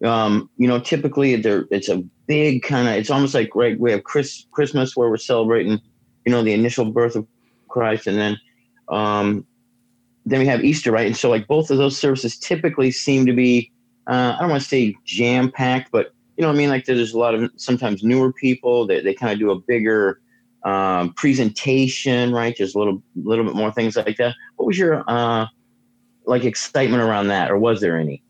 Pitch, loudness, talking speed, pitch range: 120 Hz, -19 LUFS, 210 wpm, 115-130 Hz